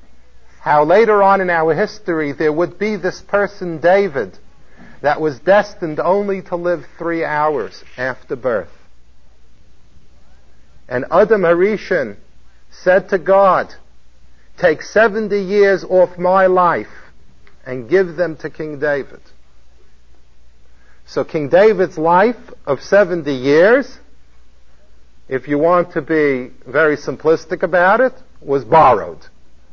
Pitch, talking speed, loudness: 160 Hz, 115 wpm, -15 LUFS